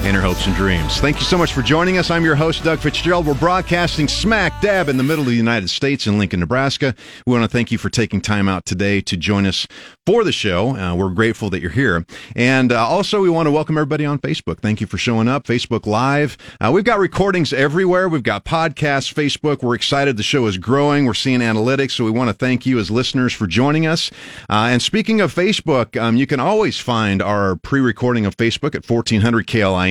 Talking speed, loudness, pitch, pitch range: 235 wpm, -17 LUFS, 125 Hz, 105-150 Hz